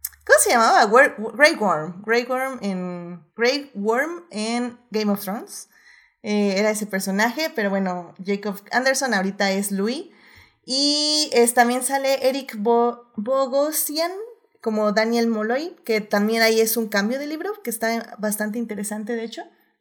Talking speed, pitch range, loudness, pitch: 140 wpm, 210-265 Hz, -21 LUFS, 230 Hz